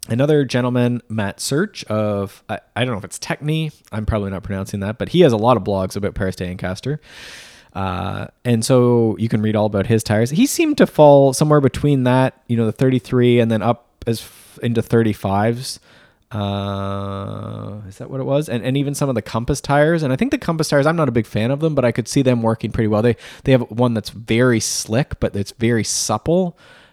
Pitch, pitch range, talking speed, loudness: 115 Hz, 105-135 Hz, 225 wpm, -18 LUFS